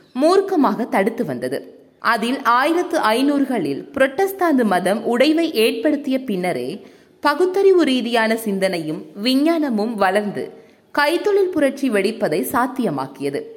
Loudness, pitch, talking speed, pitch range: -18 LUFS, 250 Hz, 90 wpm, 210-310 Hz